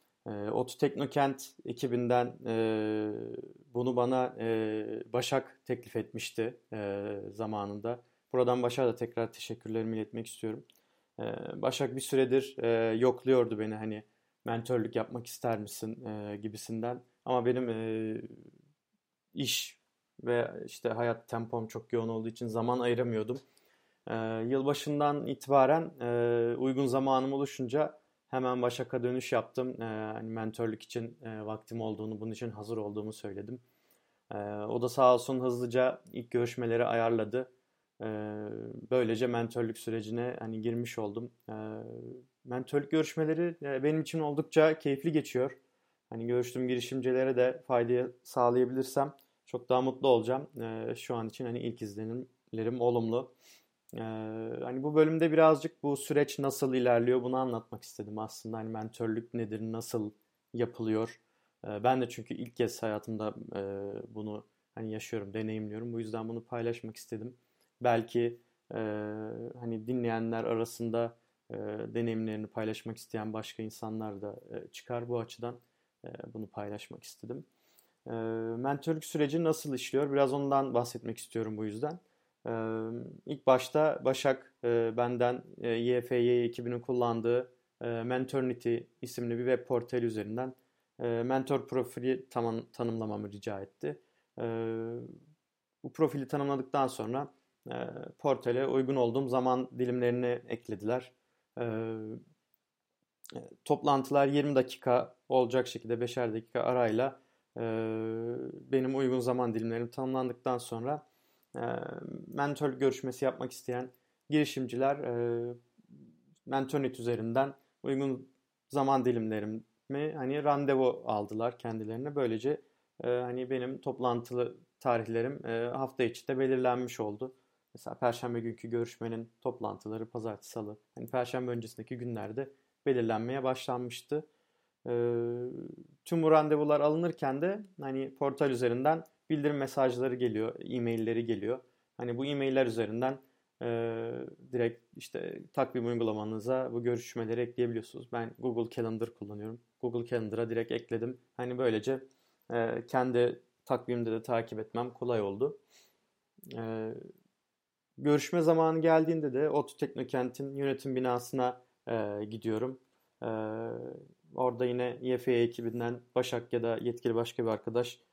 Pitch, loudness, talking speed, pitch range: 120 Hz, -33 LUFS, 120 wpm, 115-130 Hz